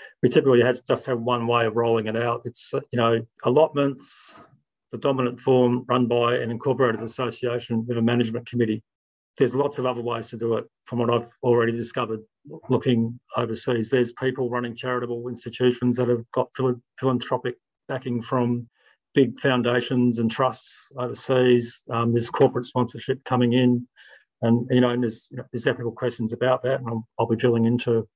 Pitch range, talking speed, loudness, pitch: 115-125 Hz, 175 wpm, -24 LUFS, 120 Hz